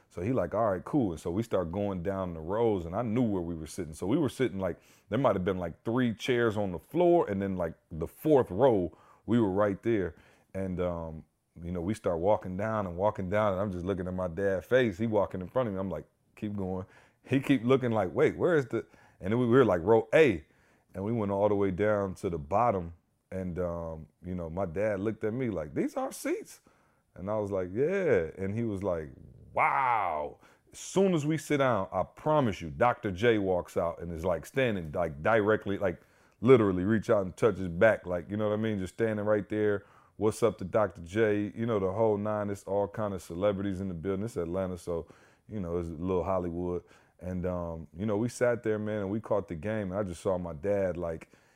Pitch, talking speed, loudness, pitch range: 100 Hz, 240 wpm, -30 LUFS, 90-110 Hz